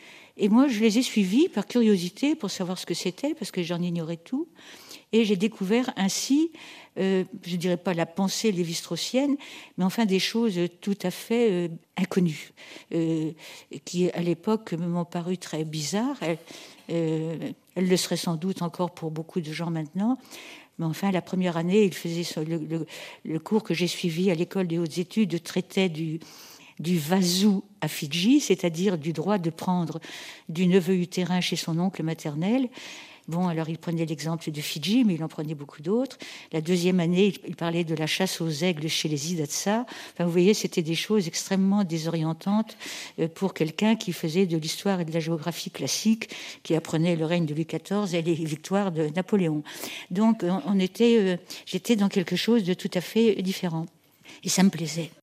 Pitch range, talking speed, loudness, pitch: 165-205 Hz, 185 wpm, -26 LUFS, 180 Hz